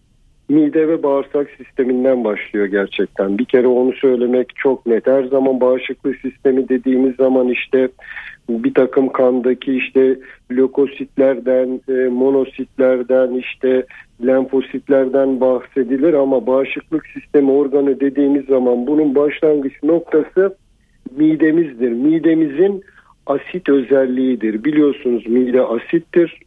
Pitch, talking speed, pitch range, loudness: 135 Hz, 100 wpm, 130-145 Hz, -16 LUFS